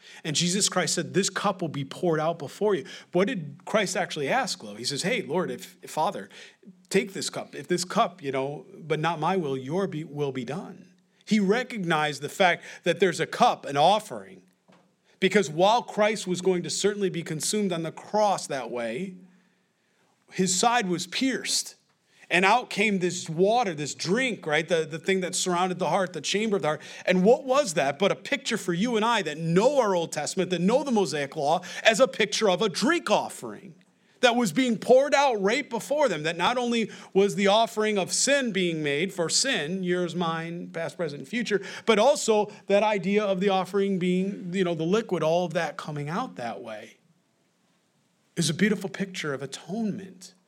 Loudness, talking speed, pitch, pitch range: -25 LUFS, 200 wpm, 190 Hz, 170-210 Hz